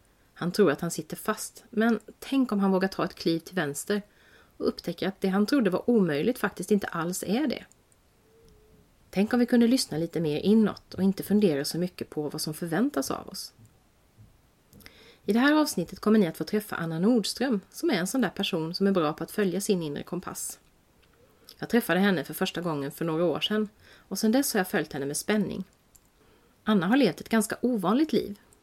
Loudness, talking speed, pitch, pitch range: -27 LUFS, 210 wpm, 195 Hz, 165-215 Hz